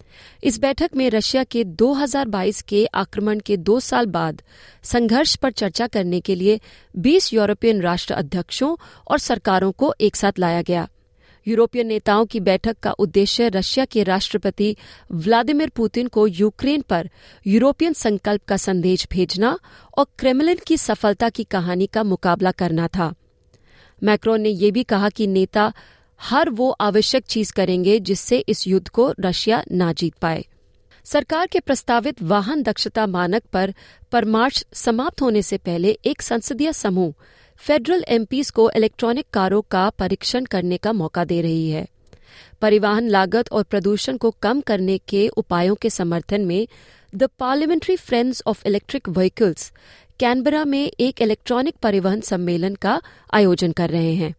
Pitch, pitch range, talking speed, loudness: 215 Hz, 190-245 Hz, 150 wpm, -20 LUFS